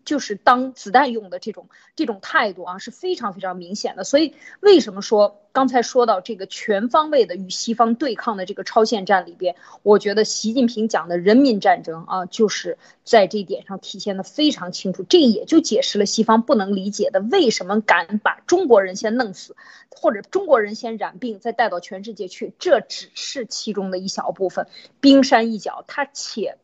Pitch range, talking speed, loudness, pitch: 195-255 Hz, 300 characters per minute, -19 LUFS, 220 Hz